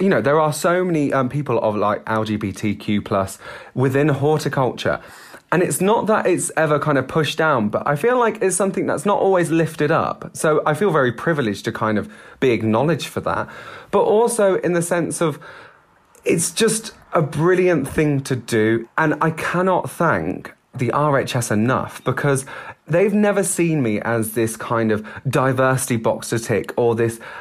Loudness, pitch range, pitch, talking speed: -19 LUFS, 115-170 Hz, 145 Hz, 175 wpm